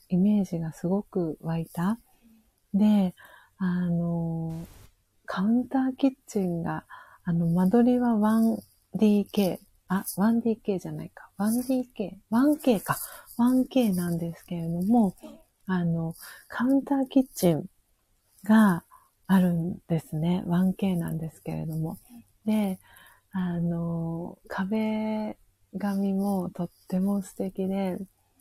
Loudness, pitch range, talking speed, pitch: -27 LUFS, 170-215 Hz, 195 characters per minute, 190 Hz